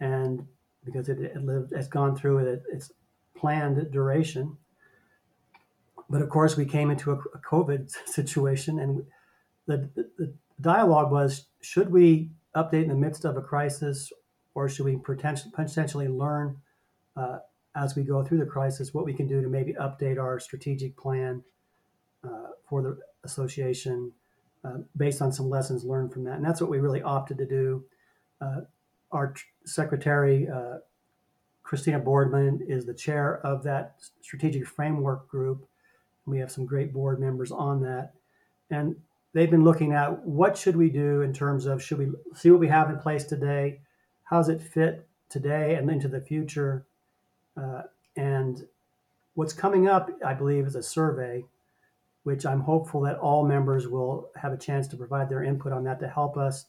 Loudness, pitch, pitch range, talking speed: -27 LUFS, 140 Hz, 135-155 Hz, 170 wpm